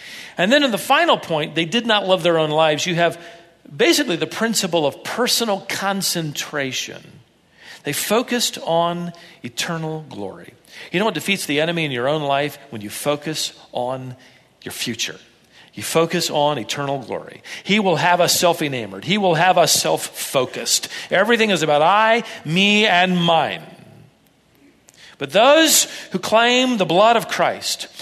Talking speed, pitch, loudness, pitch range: 160 wpm, 170 Hz, -18 LUFS, 155-205 Hz